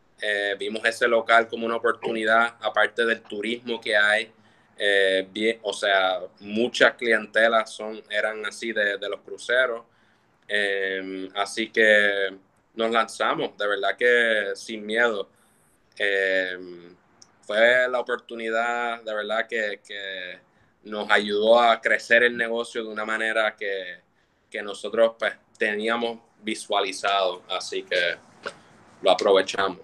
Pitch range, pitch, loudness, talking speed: 100-115 Hz, 110 Hz, -23 LUFS, 125 wpm